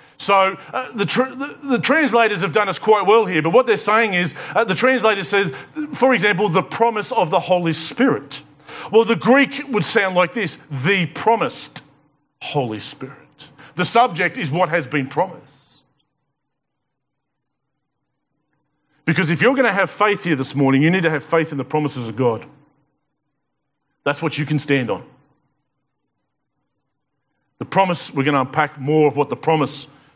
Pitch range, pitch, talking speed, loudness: 145-205 Hz, 155 Hz, 170 wpm, -18 LUFS